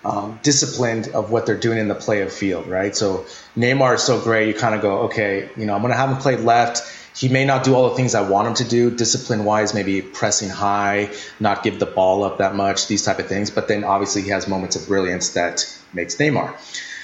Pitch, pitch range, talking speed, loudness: 105 Hz, 100-120 Hz, 245 wpm, -19 LUFS